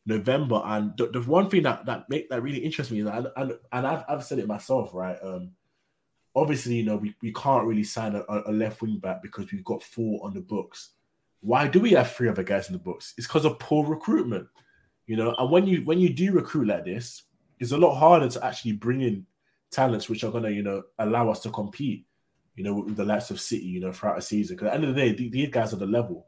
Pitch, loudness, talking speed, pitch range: 115 Hz, -26 LUFS, 265 wpm, 105-135 Hz